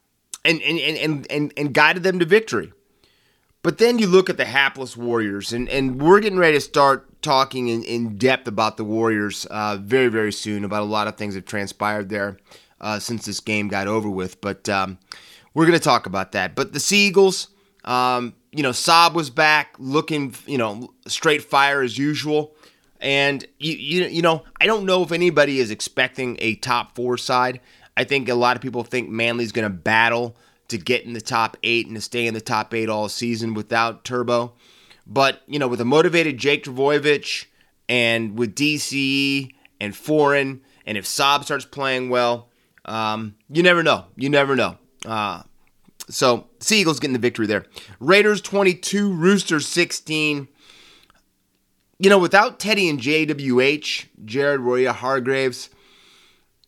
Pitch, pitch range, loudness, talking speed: 130 Hz, 115-150 Hz, -20 LUFS, 175 wpm